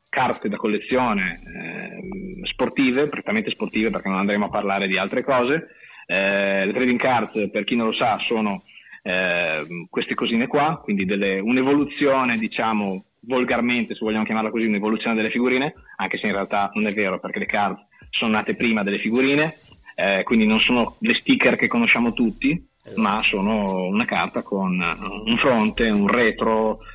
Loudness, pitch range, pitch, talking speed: -21 LUFS, 100-145 Hz, 115 Hz, 165 wpm